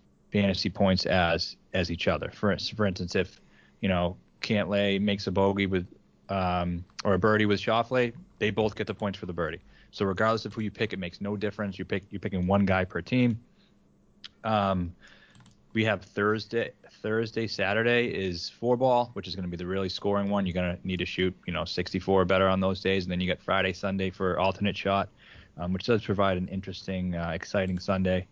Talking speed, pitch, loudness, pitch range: 210 wpm, 95 Hz, -28 LUFS, 90-105 Hz